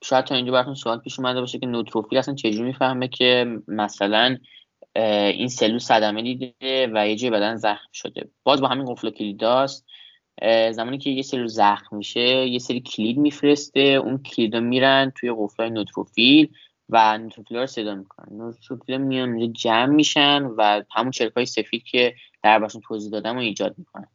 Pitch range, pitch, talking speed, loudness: 110-130 Hz, 120 Hz, 170 wpm, -21 LUFS